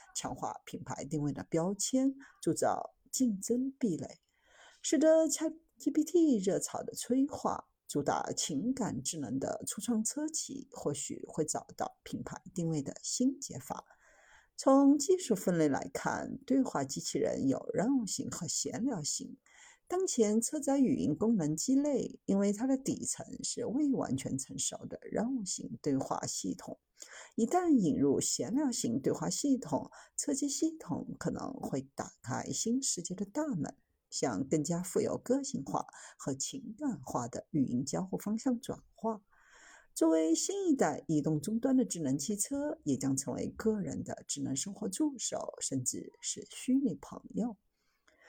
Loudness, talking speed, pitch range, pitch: -34 LUFS, 225 characters per minute, 200-280 Hz, 245 Hz